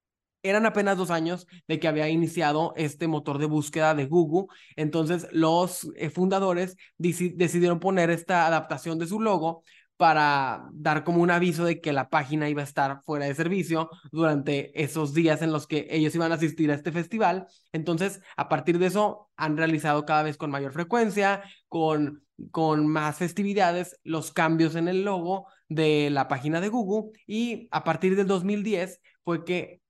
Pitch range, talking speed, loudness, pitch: 155-180 Hz, 175 wpm, -26 LUFS, 165 Hz